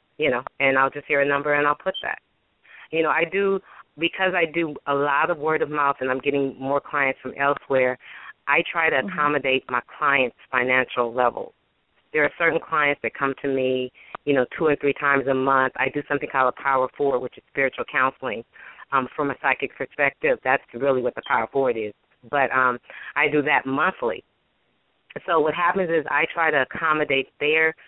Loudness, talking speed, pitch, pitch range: -22 LUFS, 200 wpm, 140 Hz, 130-155 Hz